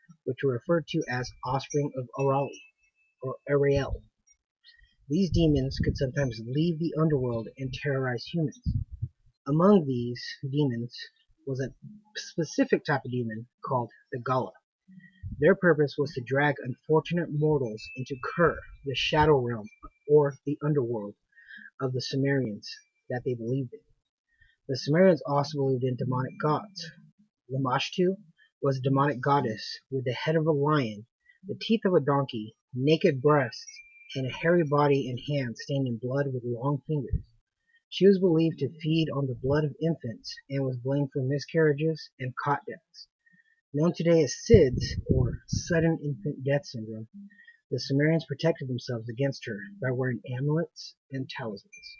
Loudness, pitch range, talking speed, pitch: -28 LUFS, 130-165 Hz, 150 wpm, 140 Hz